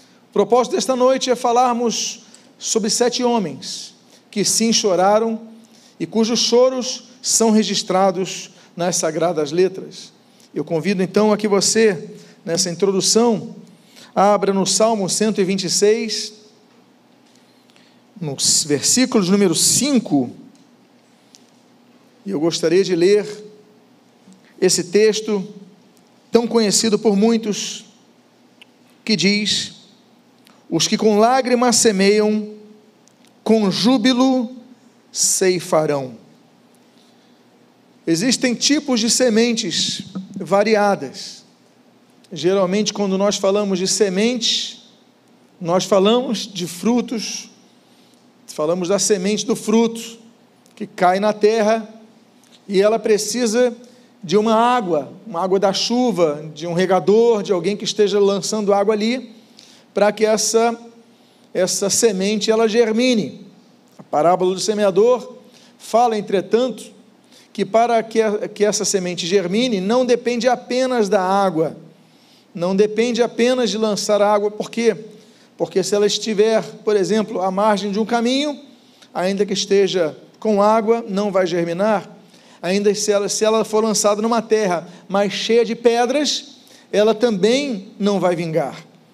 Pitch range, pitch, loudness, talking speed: 200-235 Hz, 215 Hz, -17 LUFS, 115 wpm